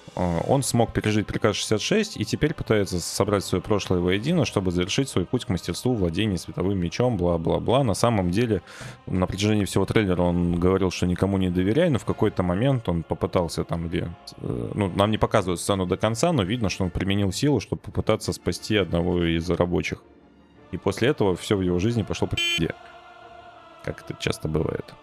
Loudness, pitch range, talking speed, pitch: -24 LUFS, 90-115 Hz, 180 wpm, 100 Hz